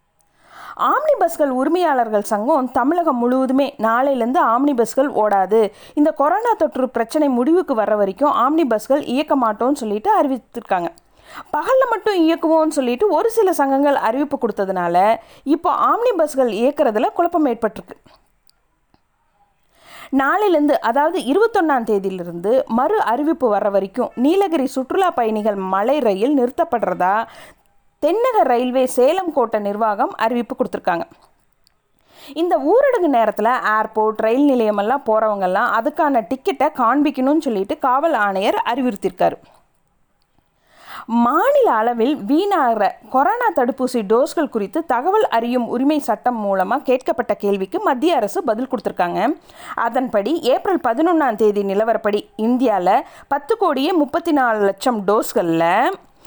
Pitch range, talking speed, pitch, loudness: 225-320 Hz, 110 wpm, 265 Hz, -18 LUFS